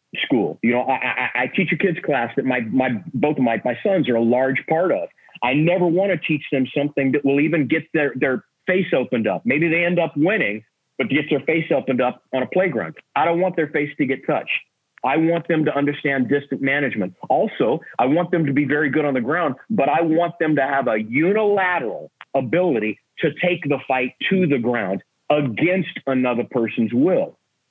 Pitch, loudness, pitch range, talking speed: 145 Hz, -20 LUFS, 130-165 Hz, 215 wpm